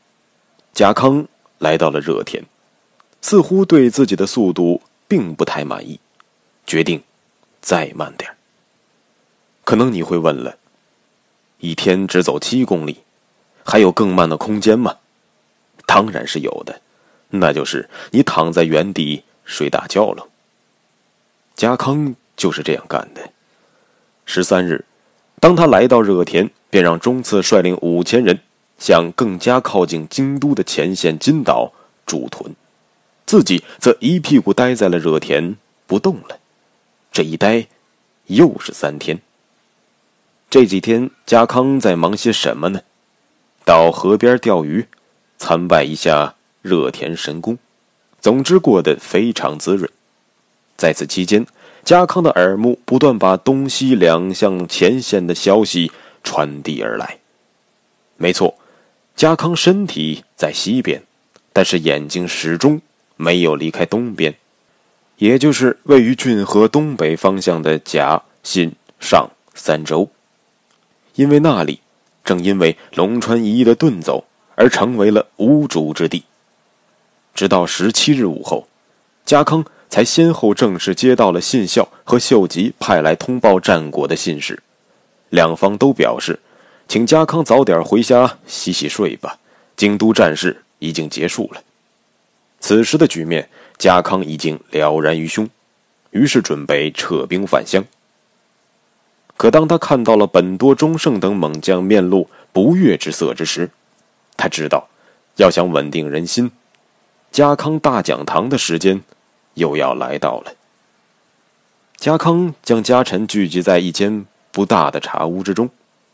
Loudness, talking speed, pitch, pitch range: -15 LUFS, 195 characters per minute, 105 Hz, 85-130 Hz